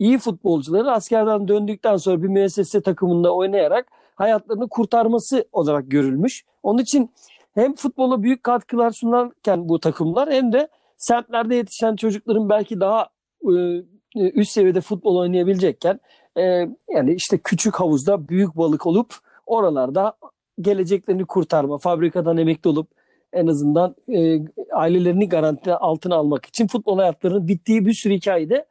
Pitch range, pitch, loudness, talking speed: 175-230 Hz, 200 Hz, -20 LUFS, 130 wpm